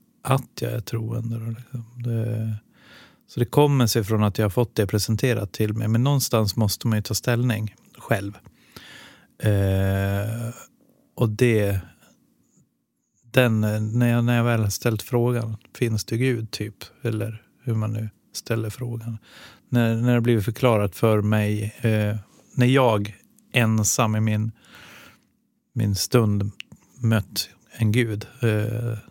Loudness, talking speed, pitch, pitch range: -23 LUFS, 140 wpm, 115 Hz, 105-120 Hz